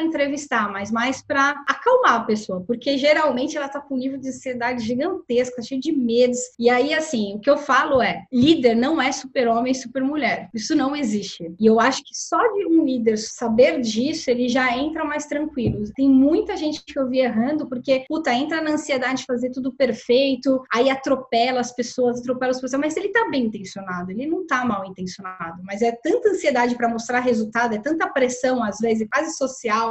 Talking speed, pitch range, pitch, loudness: 205 wpm, 235-285 Hz, 255 Hz, -21 LUFS